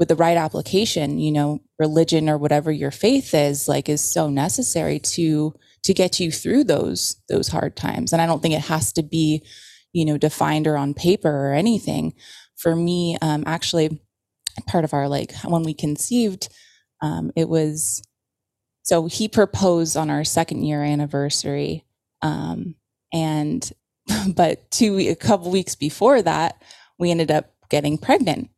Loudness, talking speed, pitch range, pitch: -21 LUFS, 160 wpm, 145-170 Hz, 155 Hz